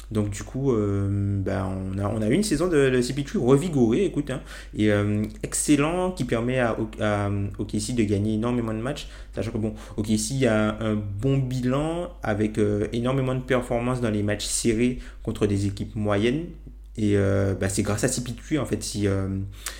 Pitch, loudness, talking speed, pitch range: 110 Hz, -25 LUFS, 190 wpm, 105-130 Hz